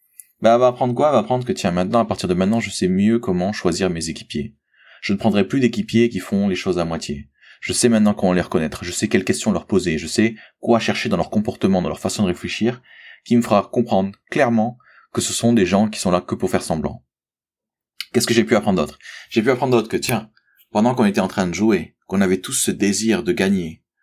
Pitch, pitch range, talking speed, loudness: 110 Hz, 100-120 Hz, 250 wpm, -19 LUFS